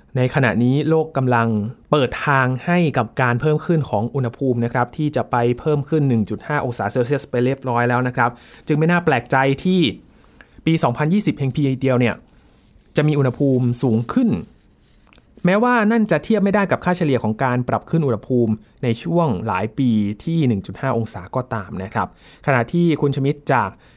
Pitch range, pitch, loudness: 120-155 Hz, 130 Hz, -19 LUFS